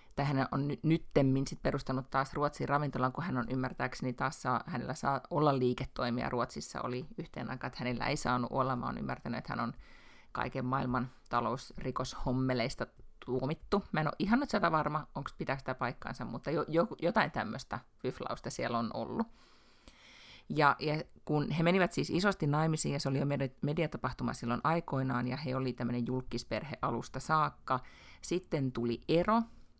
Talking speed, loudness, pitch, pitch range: 165 wpm, -34 LUFS, 135 Hz, 125-155 Hz